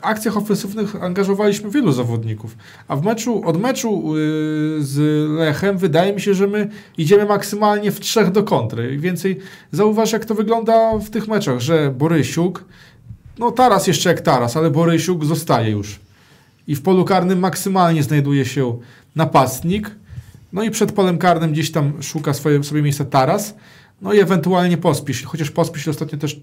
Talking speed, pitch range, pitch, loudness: 165 wpm, 150-200 Hz, 170 Hz, -17 LUFS